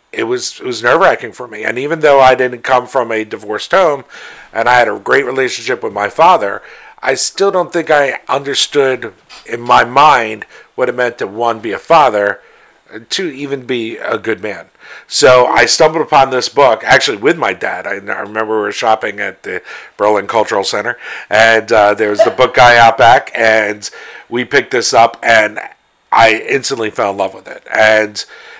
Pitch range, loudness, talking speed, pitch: 110-140 Hz, -11 LUFS, 195 wpm, 125 Hz